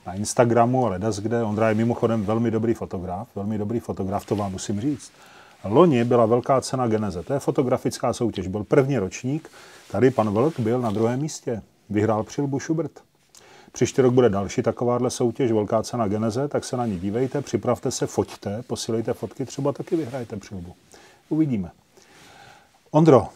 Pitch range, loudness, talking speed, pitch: 105-130 Hz, -23 LUFS, 165 wpm, 115 Hz